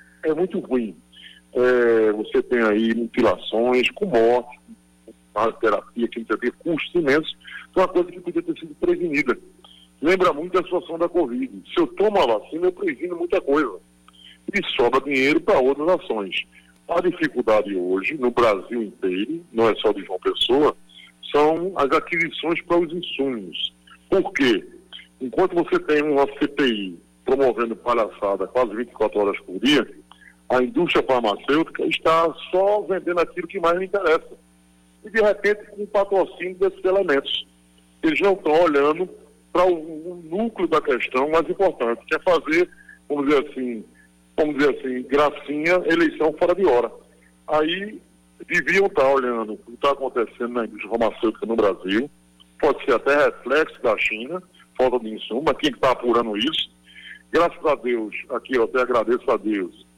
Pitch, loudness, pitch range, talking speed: 140 Hz, -21 LUFS, 110-180 Hz, 160 wpm